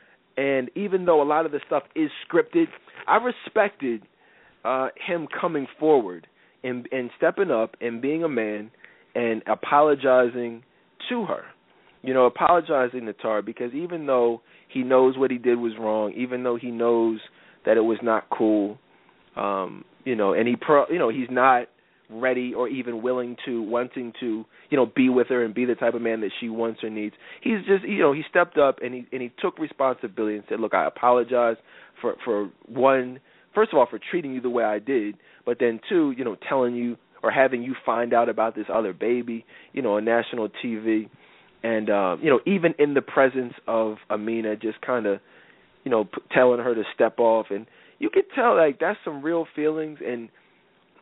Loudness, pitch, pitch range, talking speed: -24 LUFS, 125 Hz, 115-140 Hz, 200 wpm